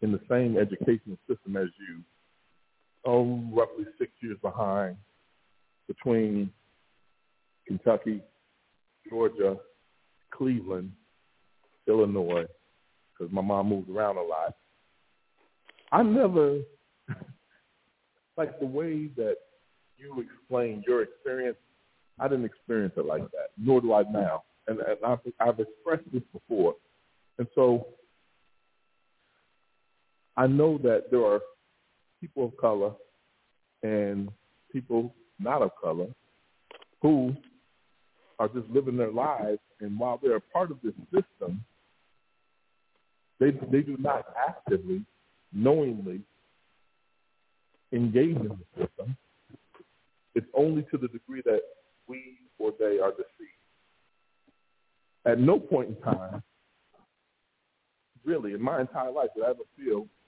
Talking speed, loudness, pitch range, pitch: 115 wpm, -29 LUFS, 105-160 Hz, 125 Hz